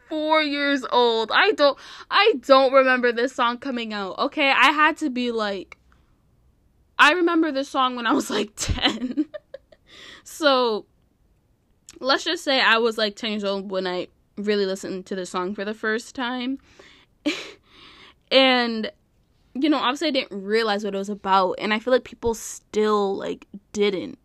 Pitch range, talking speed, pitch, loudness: 210-285 Hz, 165 wpm, 245 Hz, -21 LUFS